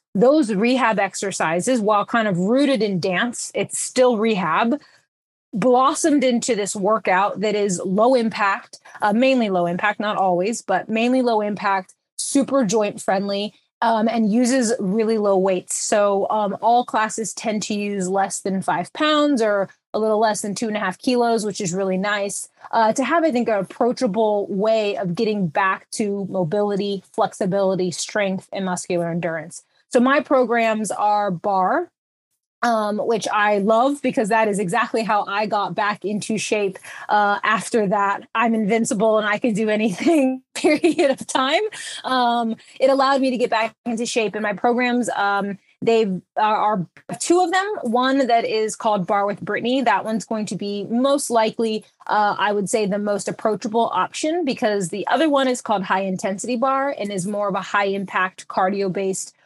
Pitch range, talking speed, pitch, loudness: 200-240 Hz, 175 wpm, 215 Hz, -20 LUFS